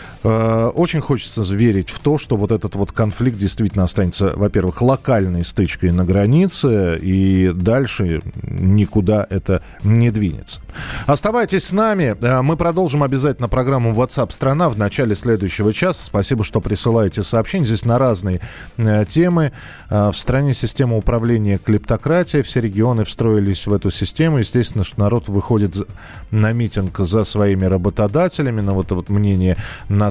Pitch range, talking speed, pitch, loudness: 100-130 Hz, 140 wpm, 110 Hz, -17 LUFS